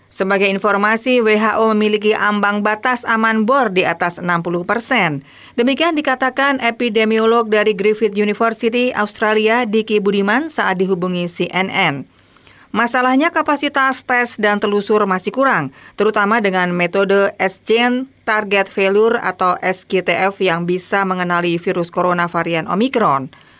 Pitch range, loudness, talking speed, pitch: 185-235 Hz, -16 LUFS, 115 wpm, 210 Hz